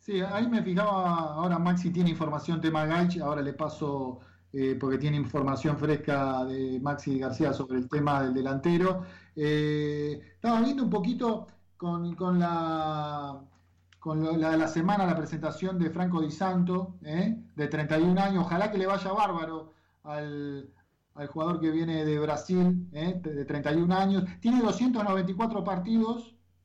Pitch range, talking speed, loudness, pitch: 145-185 Hz, 160 wpm, -29 LUFS, 160 Hz